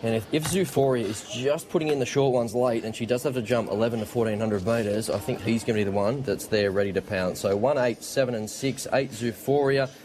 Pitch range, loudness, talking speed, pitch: 110-135 Hz, -26 LUFS, 255 wpm, 120 Hz